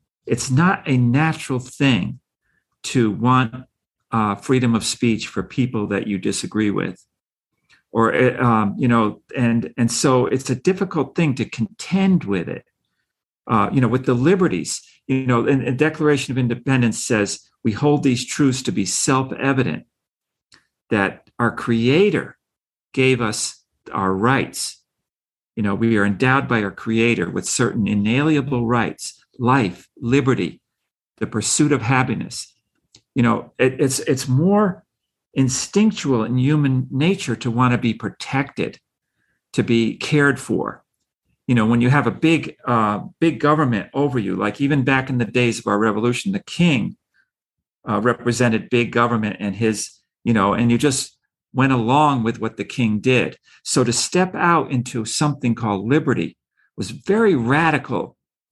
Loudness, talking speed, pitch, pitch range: -19 LUFS, 155 wpm, 125 Hz, 115-140 Hz